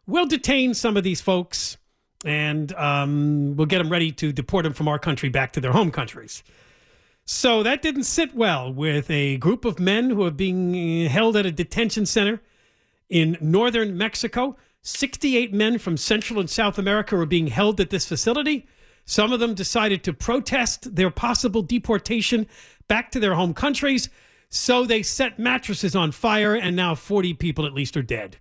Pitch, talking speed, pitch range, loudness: 200 Hz, 180 wpm, 165-230 Hz, -22 LUFS